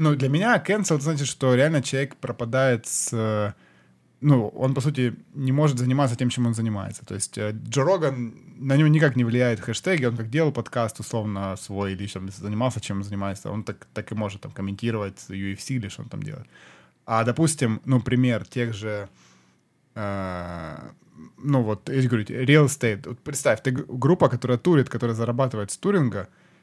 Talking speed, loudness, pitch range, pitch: 180 wpm, -24 LUFS, 105-135 Hz, 120 Hz